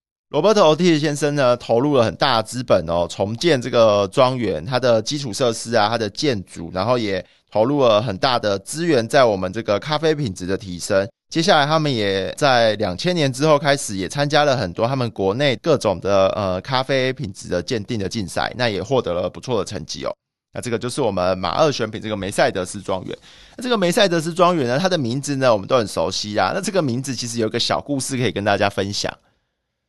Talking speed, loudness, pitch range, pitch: 335 characters per minute, -19 LUFS, 100-145 Hz, 120 Hz